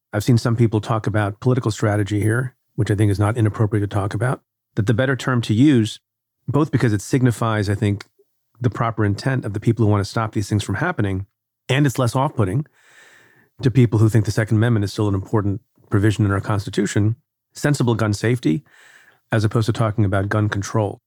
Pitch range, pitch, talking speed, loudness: 105-125 Hz, 110 Hz, 210 wpm, -20 LUFS